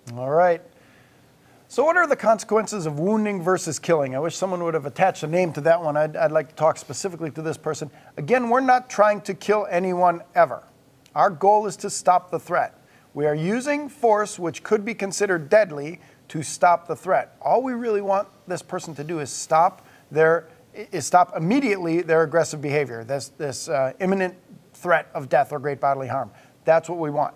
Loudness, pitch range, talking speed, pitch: -22 LUFS, 150-200 Hz, 200 wpm, 170 Hz